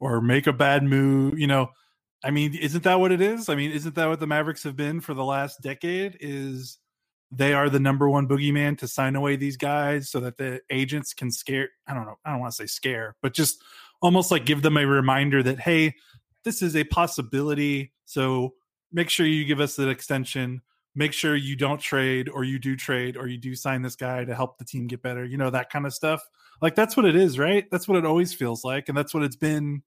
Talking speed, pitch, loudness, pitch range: 240 wpm, 140 Hz, -24 LUFS, 130-155 Hz